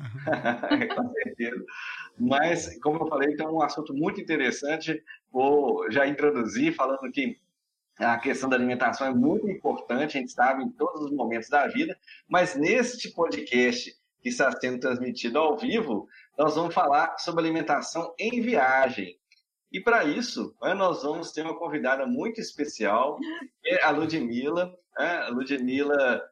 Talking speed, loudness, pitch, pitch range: 145 wpm, -26 LUFS, 155 Hz, 135-225 Hz